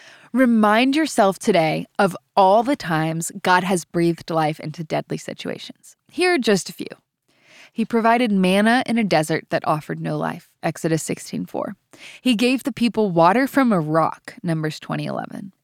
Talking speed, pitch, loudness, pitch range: 165 wpm, 200 Hz, -20 LUFS, 165-235 Hz